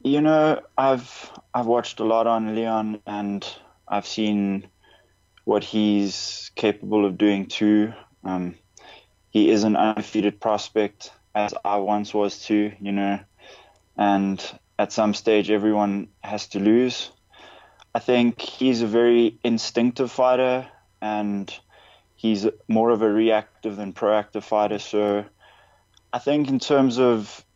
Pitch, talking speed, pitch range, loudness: 105 Hz, 135 wpm, 105-115 Hz, -23 LUFS